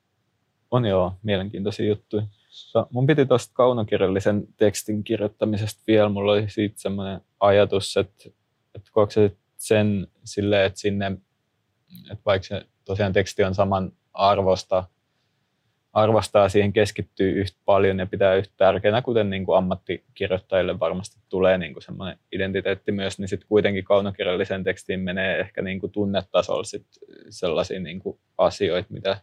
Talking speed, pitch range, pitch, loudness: 135 wpm, 95-105 Hz, 100 Hz, -23 LUFS